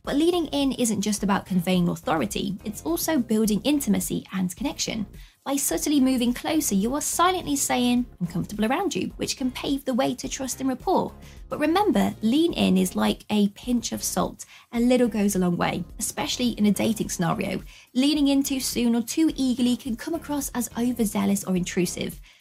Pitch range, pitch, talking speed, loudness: 205-275 Hz, 245 Hz, 185 wpm, -24 LUFS